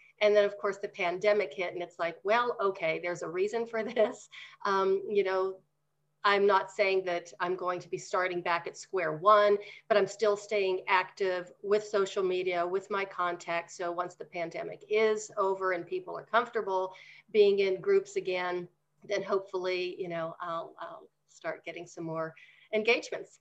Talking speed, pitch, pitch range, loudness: 175 wpm, 190 Hz, 175-210 Hz, -30 LUFS